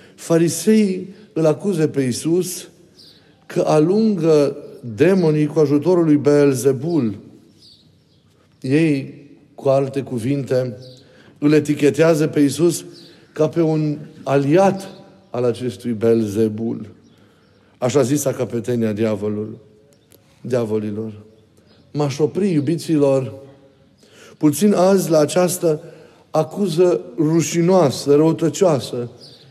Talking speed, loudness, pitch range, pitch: 85 wpm, -18 LUFS, 130-165 Hz, 150 Hz